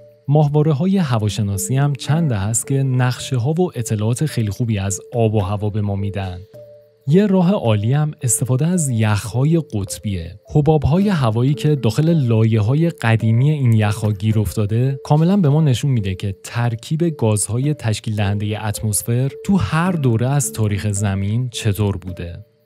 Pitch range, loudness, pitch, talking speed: 105-150 Hz, -18 LUFS, 120 Hz, 150 wpm